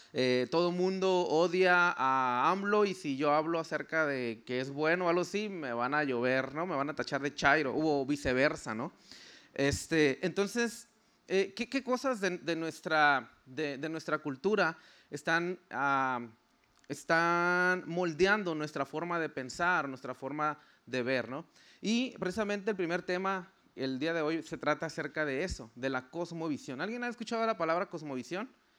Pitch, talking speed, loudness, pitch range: 165 Hz, 170 wpm, -32 LUFS, 140-185 Hz